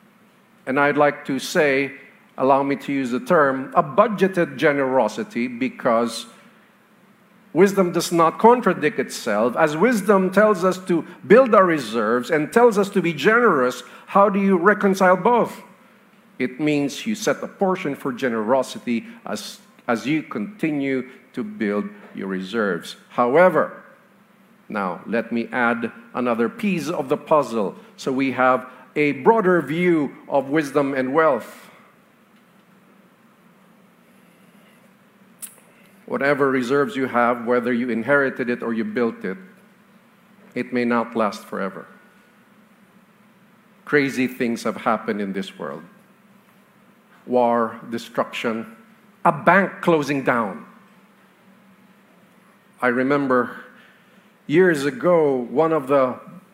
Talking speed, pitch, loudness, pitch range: 120 wpm, 185 Hz, -20 LUFS, 135-210 Hz